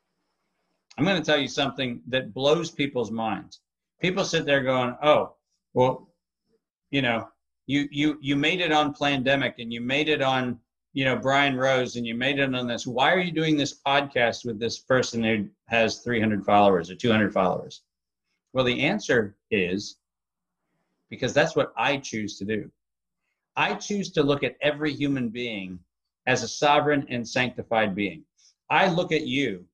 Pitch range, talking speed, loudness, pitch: 115-145 Hz, 170 wpm, -25 LUFS, 130 Hz